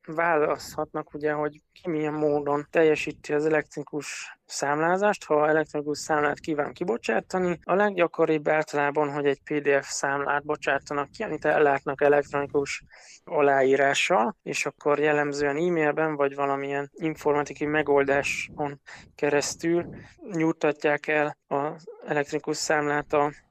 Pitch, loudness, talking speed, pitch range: 150 Hz, -26 LUFS, 110 wpm, 145-155 Hz